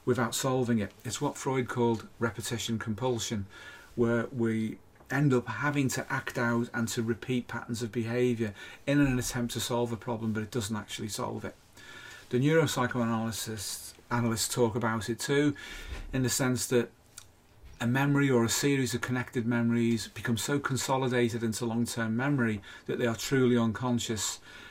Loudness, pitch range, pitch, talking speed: -30 LUFS, 115-125 Hz, 120 Hz, 165 wpm